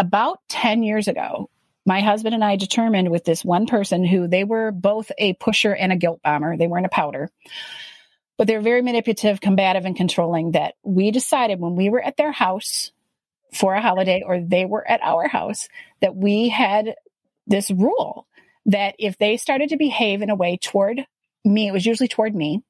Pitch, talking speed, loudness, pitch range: 205 Hz, 195 wpm, -20 LUFS, 185-225 Hz